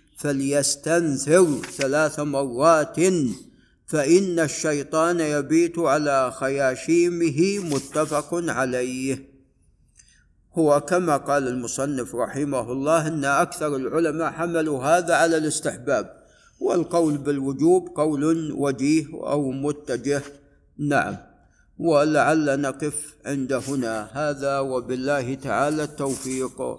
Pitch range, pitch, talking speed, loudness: 135-160 Hz, 145 Hz, 85 wpm, -23 LUFS